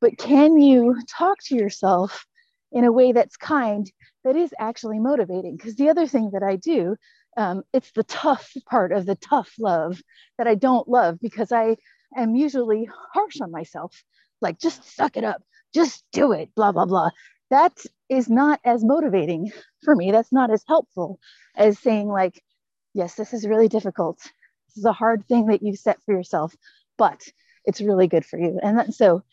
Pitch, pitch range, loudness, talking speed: 230 Hz, 205-275 Hz, -21 LUFS, 185 wpm